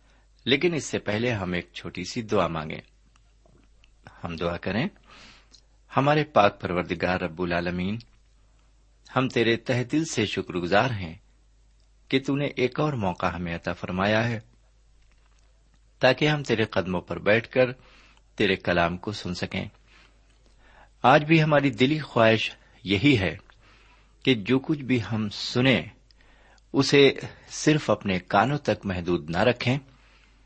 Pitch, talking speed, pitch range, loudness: 110 Hz, 135 wpm, 95-130 Hz, -25 LUFS